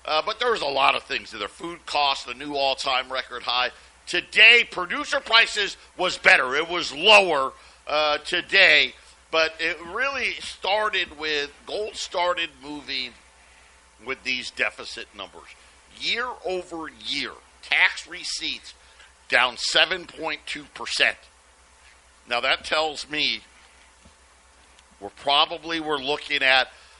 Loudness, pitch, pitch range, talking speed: -22 LUFS, 145 Hz, 100-170 Hz, 120 wpm